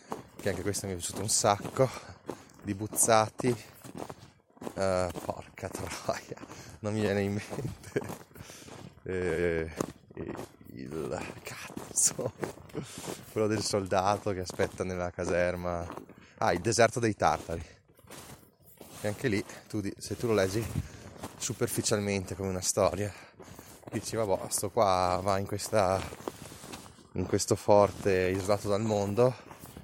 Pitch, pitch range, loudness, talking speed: 100 Hz, 95-110 Hz, -30 LUFS, 115 wpm